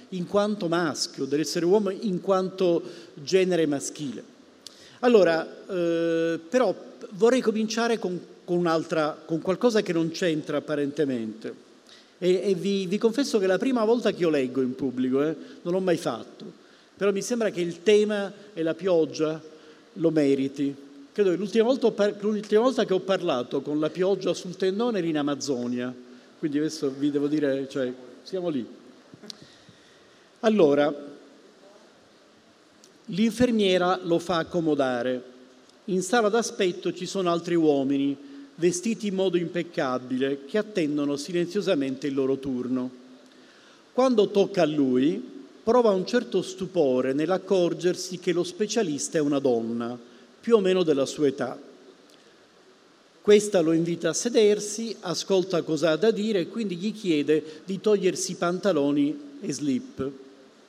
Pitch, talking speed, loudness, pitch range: 175 Hz, 140 wpm, -25 LUFS, 145-205 Hz